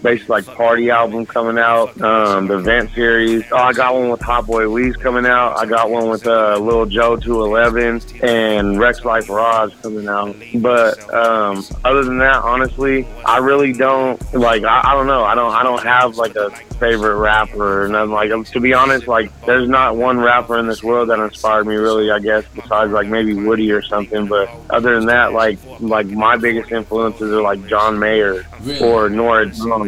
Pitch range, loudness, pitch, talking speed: 110-120 Hz, -14 LUFS, 115 Hz, 200 wpm